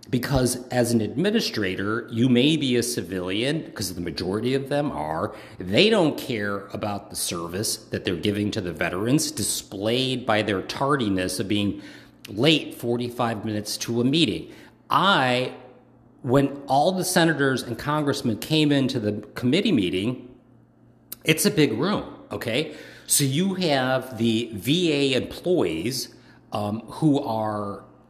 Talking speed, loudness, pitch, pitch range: 140 wpm, -24 LUFS, 120 Hz, 110-140 Hz